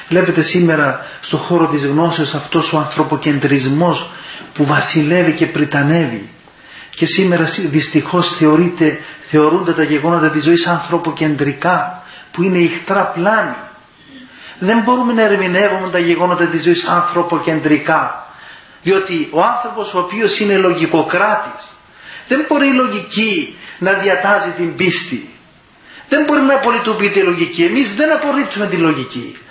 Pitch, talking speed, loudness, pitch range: 175 Hz, 125 wpm, -14 LUFS, 155-200 Hz